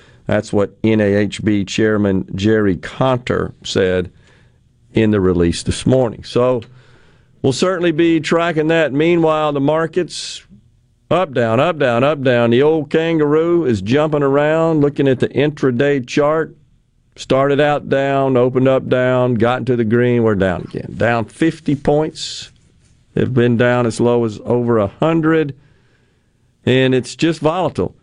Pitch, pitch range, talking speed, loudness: 125 Hz, 115-150 Hz, 140 wpm, -16 LUFS